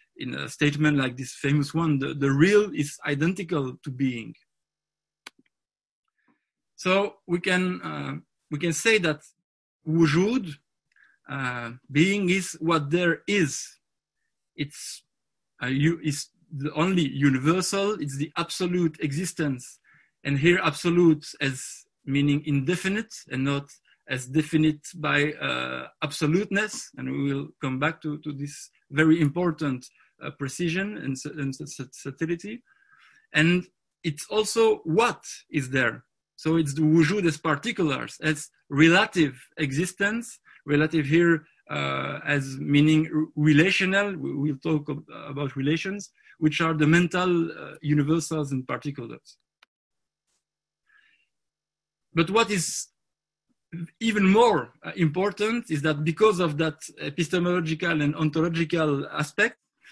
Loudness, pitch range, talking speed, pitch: -25 LUFS, 145-180 Hz, 120 wpm, 160 Hz